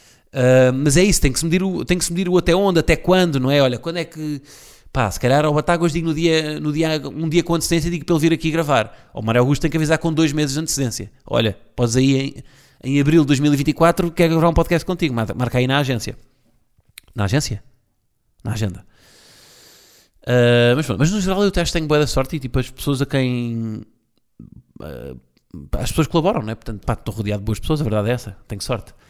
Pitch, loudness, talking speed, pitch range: 140 Hz, -19 LUFS, 235 wpm, 120-165 Hz